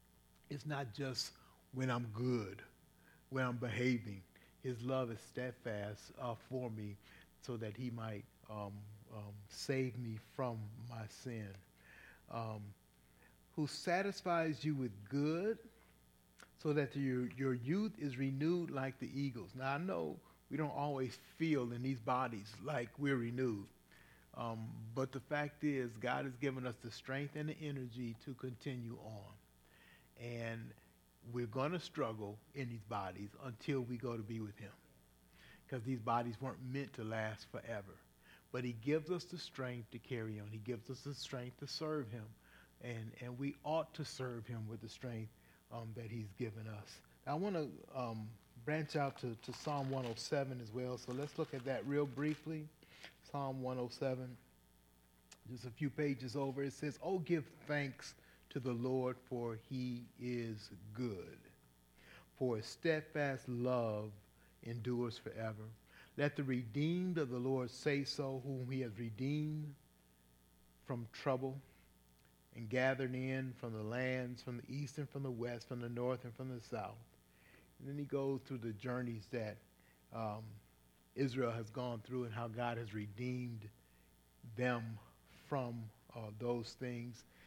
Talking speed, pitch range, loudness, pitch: 155 wpm, 110-135 Hz, -43 LUFS, 125 Hz